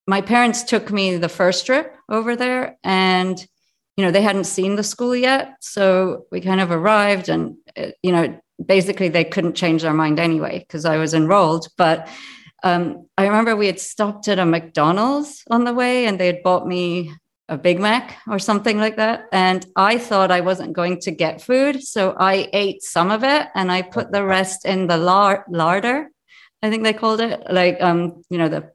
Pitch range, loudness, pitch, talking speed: 175-220 Hz, -18 LUFS, 190 Hz, 200 wpm